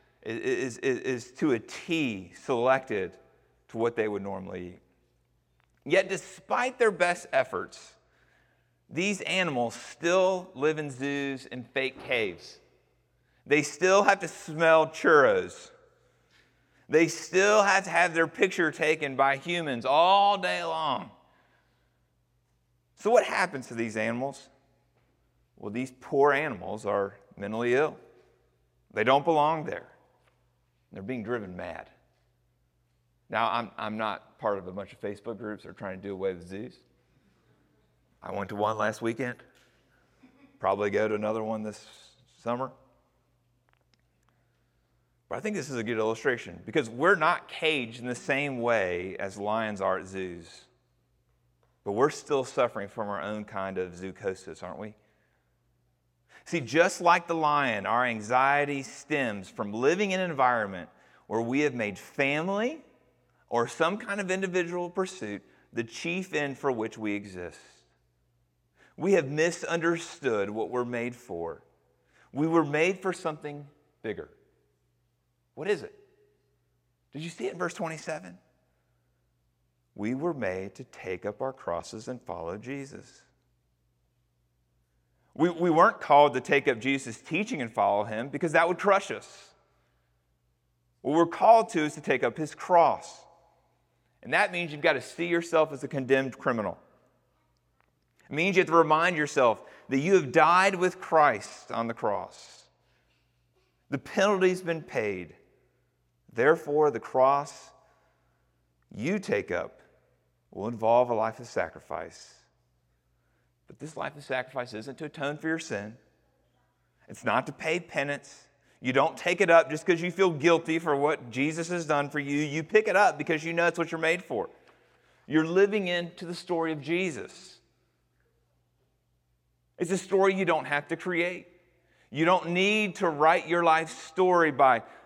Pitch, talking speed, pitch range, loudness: 135 Hz, 150 wpm, 100-170 Hz, -27 LUFS